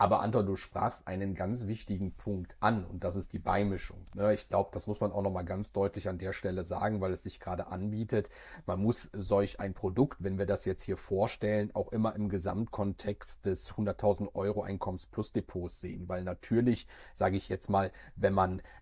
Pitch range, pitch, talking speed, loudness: 95-105 Hz, 100 Hz, 200 wpm, -34 LUFS